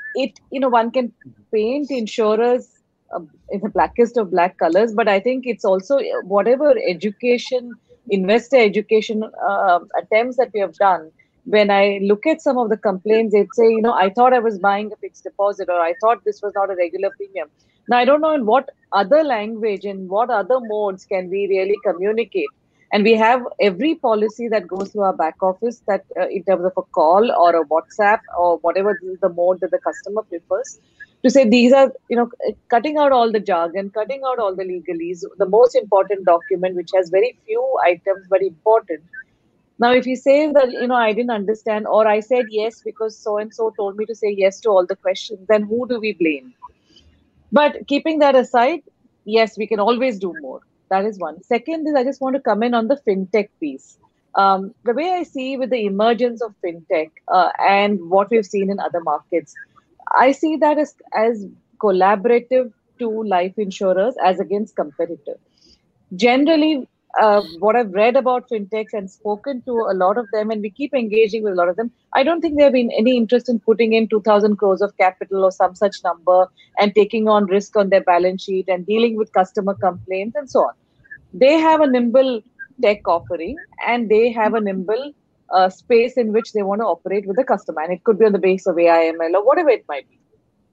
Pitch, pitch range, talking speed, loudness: 215 Hz, 195-245 Hz, 205 wpm, -18 LUFS